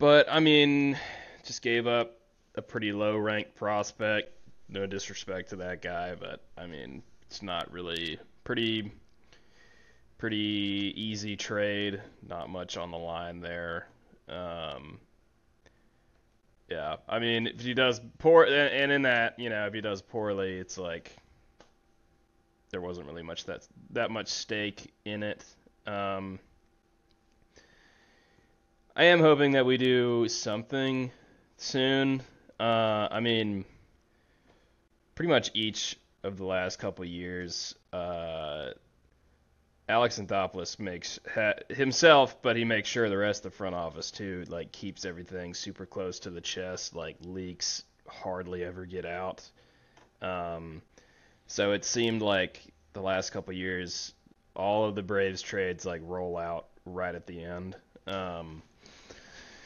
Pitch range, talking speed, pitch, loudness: 90-115 Hz, 135 wpm, 100 Hz, -30 LUFS